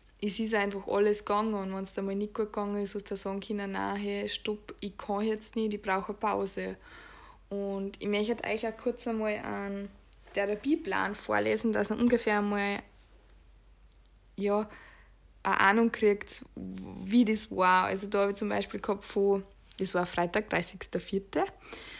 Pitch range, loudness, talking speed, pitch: 195-215 Hz, -31 LUFS, 175 wpm, 205 Hz